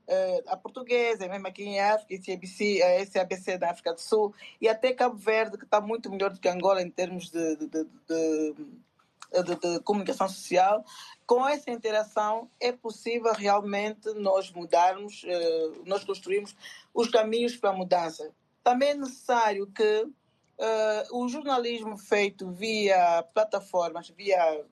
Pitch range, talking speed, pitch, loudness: 180-225 Hz, 150 wpm, 200 Hz, -28 LUFS